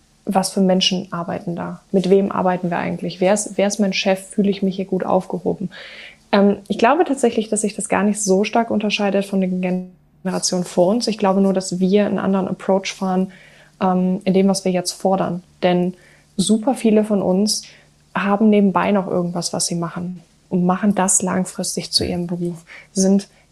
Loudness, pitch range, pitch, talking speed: -19 LUFS, 185-205 Hz, 190 Hz, 195 wpm